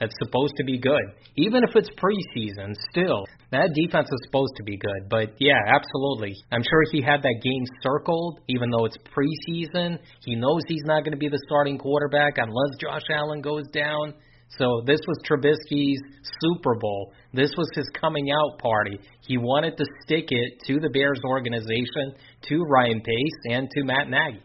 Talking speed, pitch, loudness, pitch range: 180 wpm, 140 Hz, -24 LUFS, 125-150 Hz